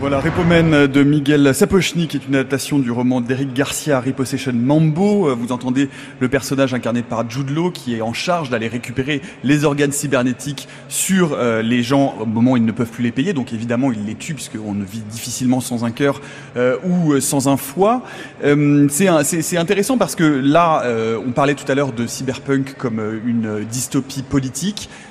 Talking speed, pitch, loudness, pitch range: 195 wpm, 135 Hz, -17 LUFS, 125-145 Hz